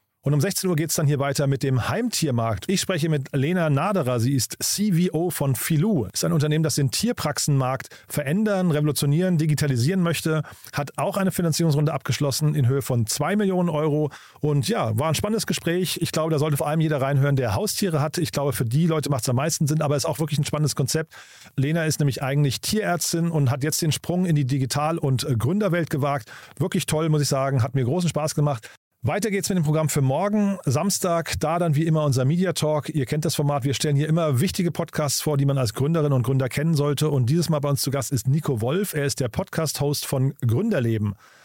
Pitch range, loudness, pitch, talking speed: 140-165 Hz, -23 LUFS, 150 Hz, 225 wpm